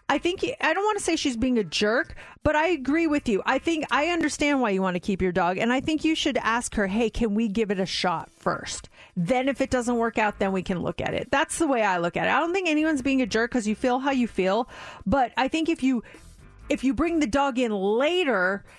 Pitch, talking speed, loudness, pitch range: 255 Hz, 275 wpm, -25 LUFS, 215-300 Hz